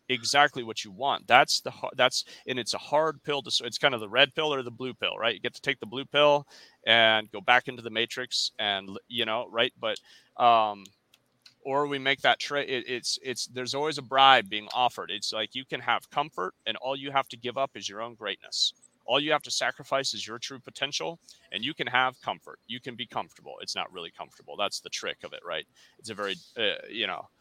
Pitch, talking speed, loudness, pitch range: 130 Hz, 240 wpm, -27 LUFS, 115-140 Hz